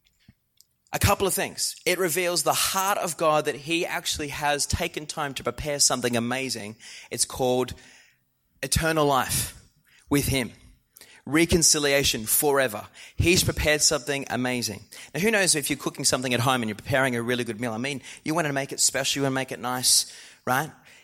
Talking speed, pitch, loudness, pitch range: 180 wpm, 140 Hz, -24 LUFS, 125-155 Hz